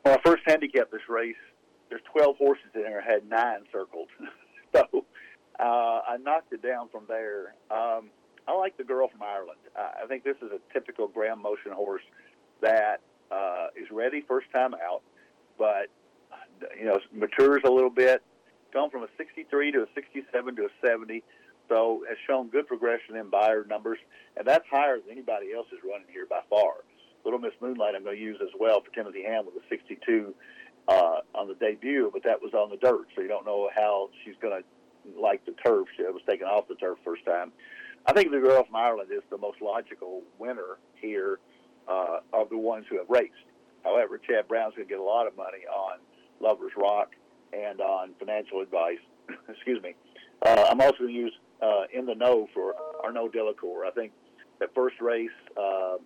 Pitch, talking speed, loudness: 140 Hz, 195 wpm, -28 LUFS